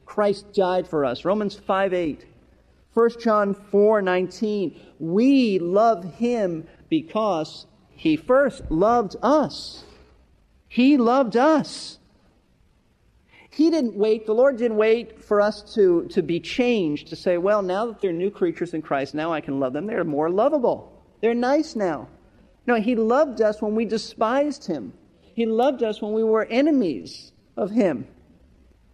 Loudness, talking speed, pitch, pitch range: -22 LUFS, 150 wpm, 215 Hz, 185-240 Hz